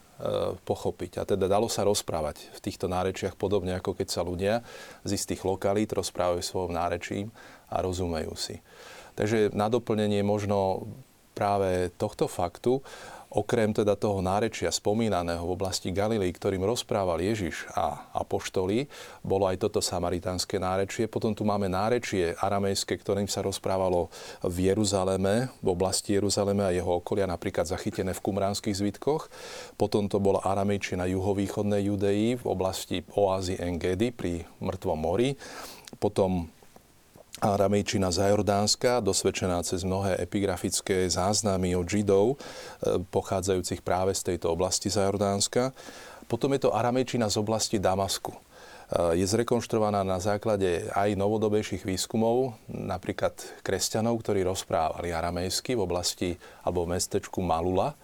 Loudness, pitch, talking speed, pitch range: -28 LUFS, 100 Hz, 130 wpm, 95-105 Hz